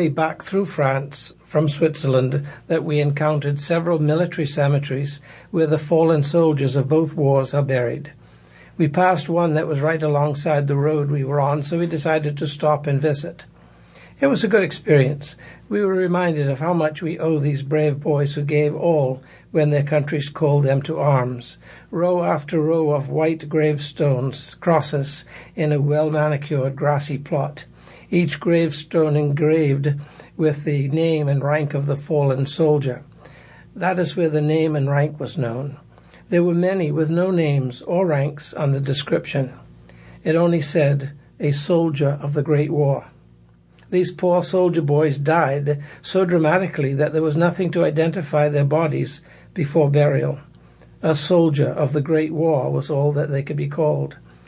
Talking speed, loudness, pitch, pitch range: 165 wpm, -20 LUFS, 150 Hz, 140-160 Hz